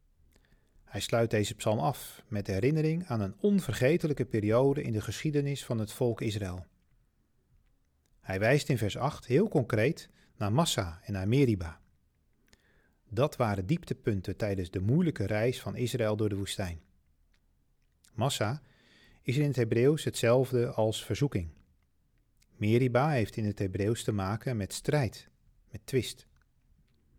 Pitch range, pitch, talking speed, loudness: 95-130 Hz, 110 Hz, 135 wpm, -30 LUFS